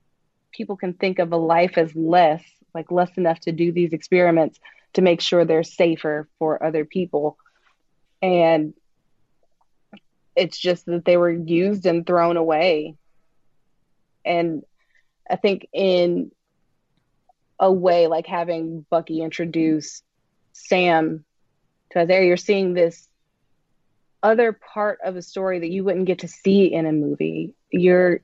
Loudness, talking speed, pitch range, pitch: -20 LUFS, 135 wpm, 160-180 Hz, 170 Hz